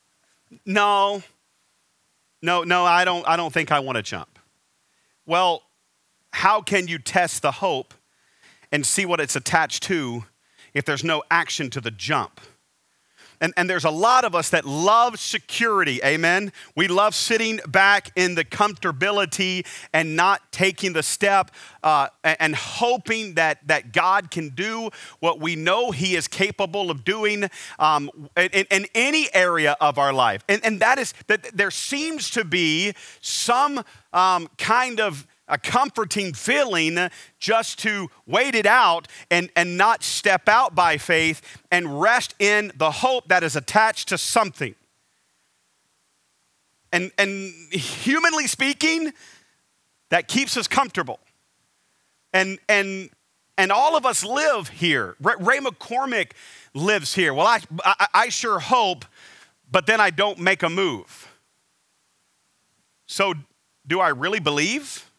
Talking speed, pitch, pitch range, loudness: 145 wpm, 185 Hz, 160-210 Hz, -21 LUFS